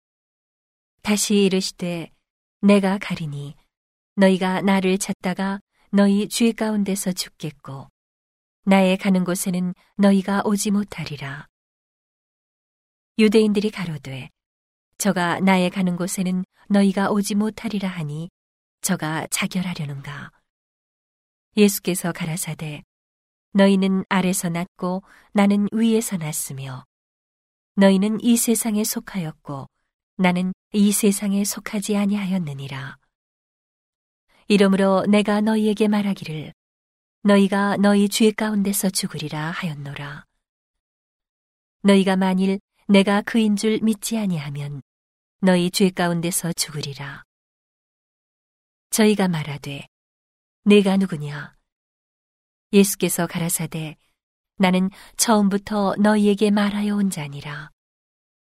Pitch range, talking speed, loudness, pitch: 155-205 Hz, 235 characters per minute, -20 LUFS, 190 Hz